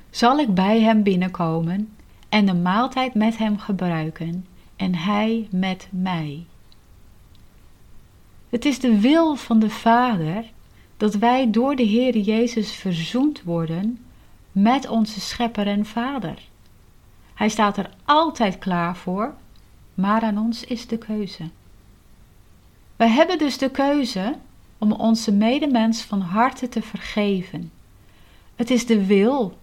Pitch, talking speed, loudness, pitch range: 215 Hz, 130 wpm, -21 LUFS, 180-235 Hz